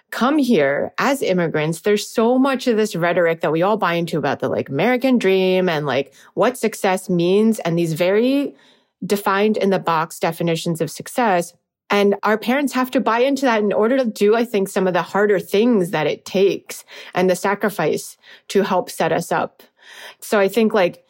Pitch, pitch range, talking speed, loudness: 200 Hz, 175-230 Hz, 195 wpm, -18 LUFS